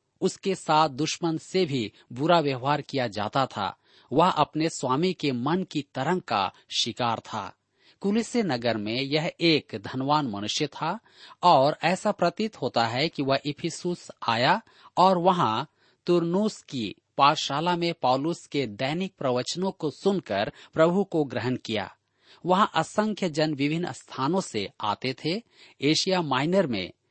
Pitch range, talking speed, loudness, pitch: 135-180 Hz, 140 wpm, -26 LUFS, 155 Hz